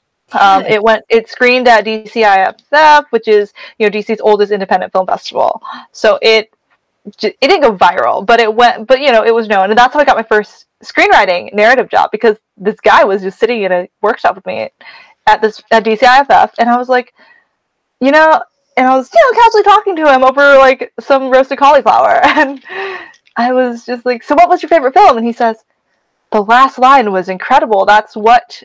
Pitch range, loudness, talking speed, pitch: 215-275 Hz, -9 LUFS, 205 wpm, 240 Hz